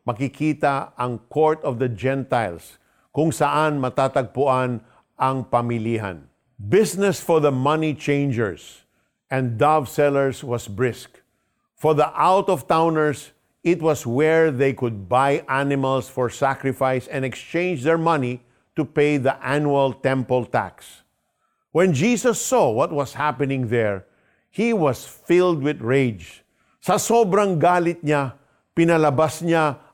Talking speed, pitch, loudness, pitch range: 120 wpm, 140 Hz, -21 LUFS, 125-155 Hz